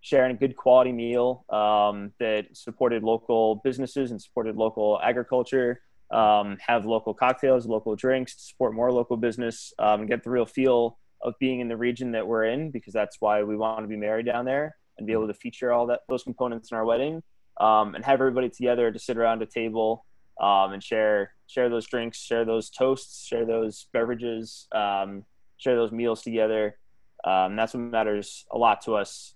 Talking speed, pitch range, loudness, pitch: 200 wpm, 110-125 Hz, -26 LUFS, 115 Hz